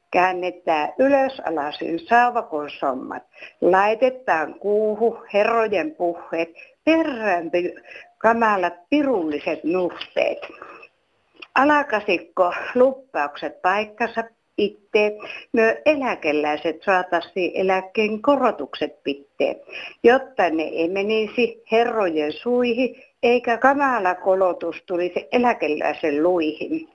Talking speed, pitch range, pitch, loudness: 80 wpm, 170-240 Hz, 205 Hz, -21 LUFS